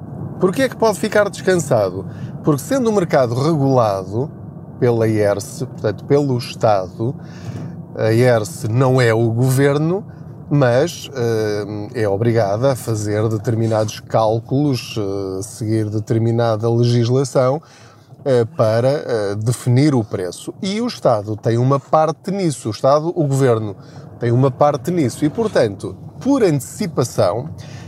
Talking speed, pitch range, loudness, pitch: 125 wpm, 115-150 Hz, -18 LUFS, 130 Hz